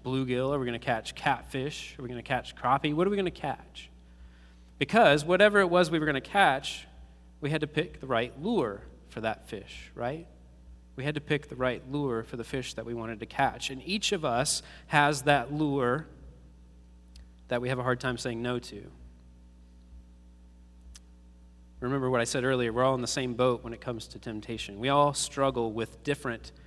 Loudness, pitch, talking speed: -29 LUFS, 120 Hz, 205 wpm